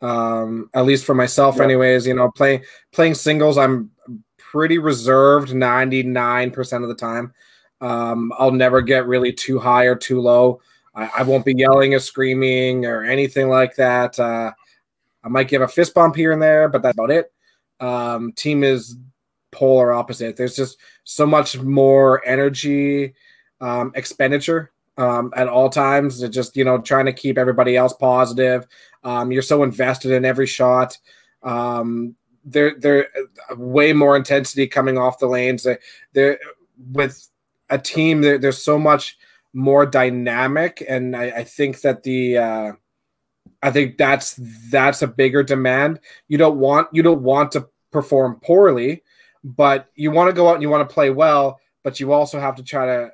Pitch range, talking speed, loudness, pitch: 125-140 Hz, 170 wpm, -17 LUFS, 130 Hz